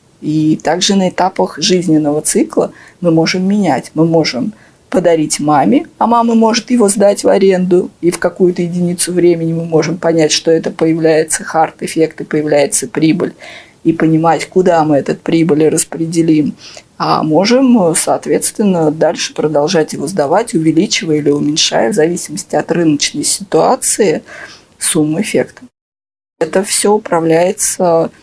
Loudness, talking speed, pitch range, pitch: -12 LUFS, 130 wpm, 155-185 Hz, 165 Hz